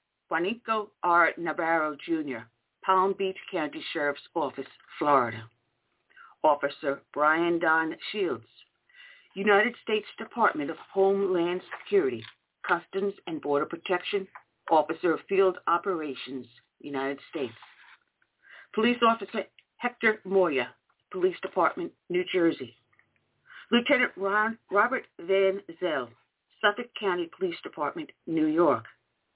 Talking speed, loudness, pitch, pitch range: 100 wpm, -28 LUFS, 190 Hz, 155-220 Hz